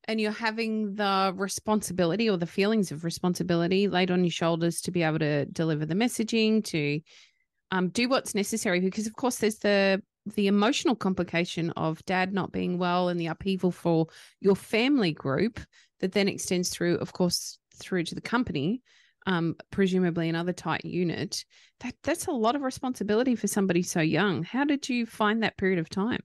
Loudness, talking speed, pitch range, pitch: -27 LUFS, 180 wpm, 170-220 Hz, 190 Hz